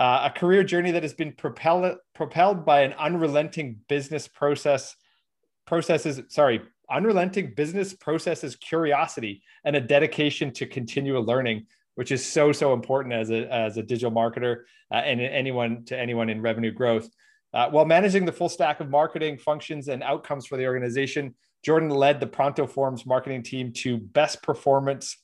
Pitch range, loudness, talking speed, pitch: 125-155 Hz, -25 LUFS, 165 wpm, 145 Hz